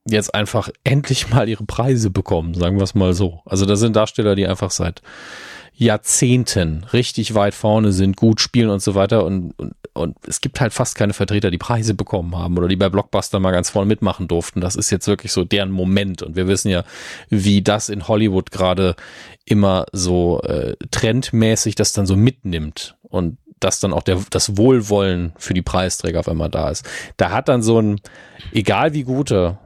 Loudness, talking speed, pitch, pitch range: -18 LUFS, 195 wpm, 100 Hz, 90-110 Hz